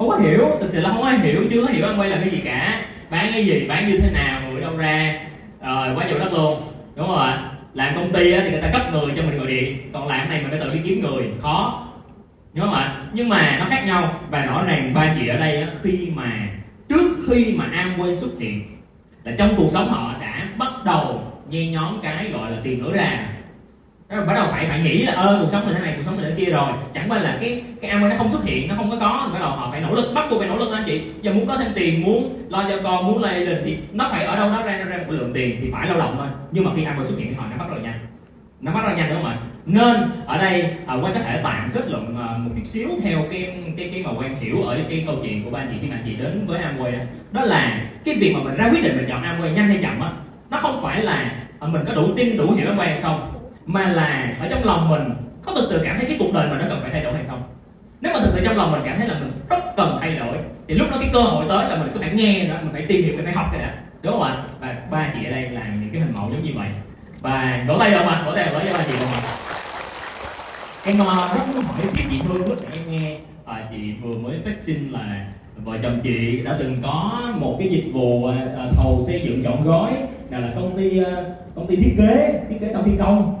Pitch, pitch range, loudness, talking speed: 165 Hz, 130-200 Hz, -20 LUFS, 285 wpm